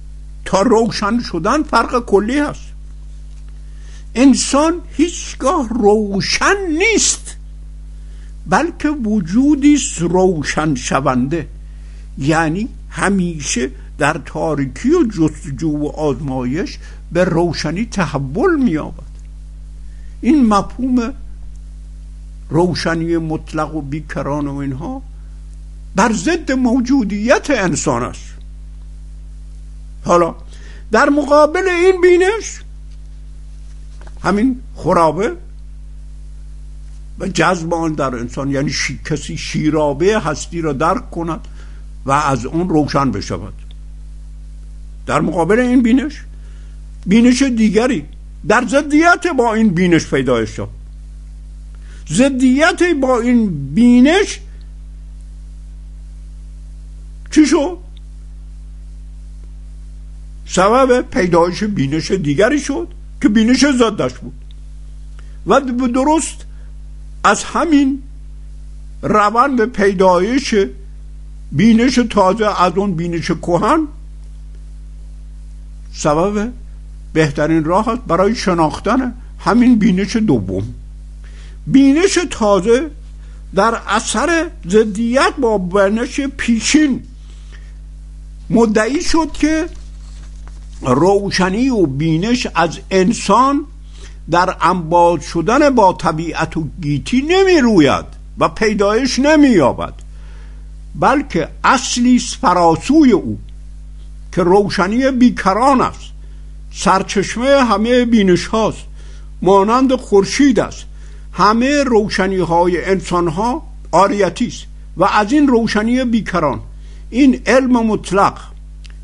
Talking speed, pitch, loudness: 85 wpm, 175 Hz, -14 LUFS